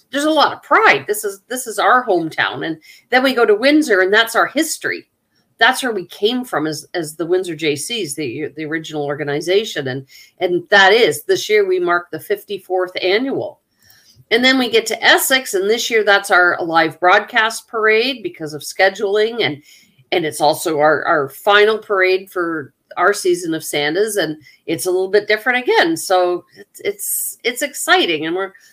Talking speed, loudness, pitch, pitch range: 190 wpm, -16 LUFS, 200 Hz, 165-250 Hz